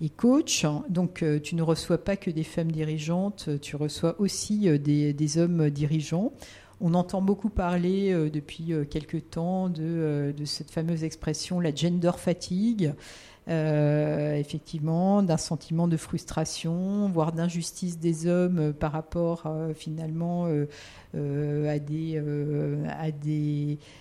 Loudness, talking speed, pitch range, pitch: -28 LUFS, 130 wpm, 150-175 Hz, 160 Hz